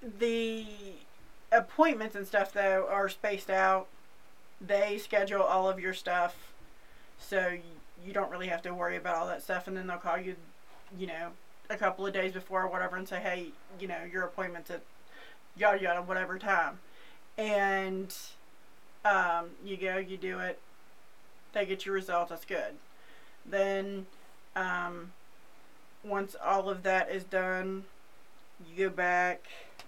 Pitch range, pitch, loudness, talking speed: 180-200 Hz, 190 Hz, -32 LUFS, 150 wpm